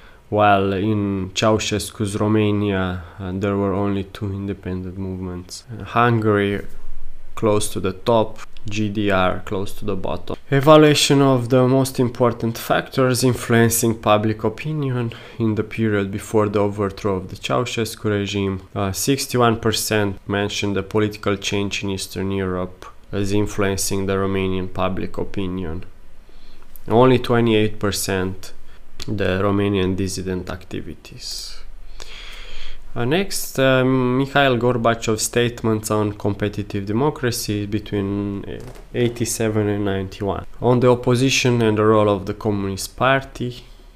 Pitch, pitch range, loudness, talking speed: 105 Hz, 95-115 Hz, -20 LUFS, 115 wpm